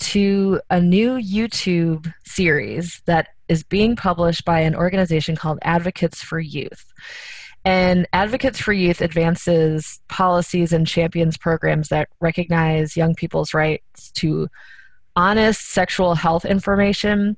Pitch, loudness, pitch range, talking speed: 170 Hz, -19 LUFS, 165-190 Hz, 120 wpm